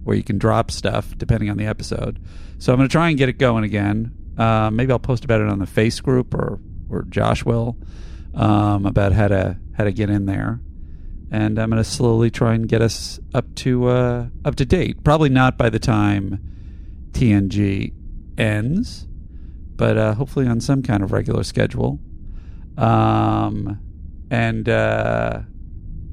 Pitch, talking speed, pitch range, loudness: 105 Hz, 175 wpm, 90-115 Hz, -19 LUFS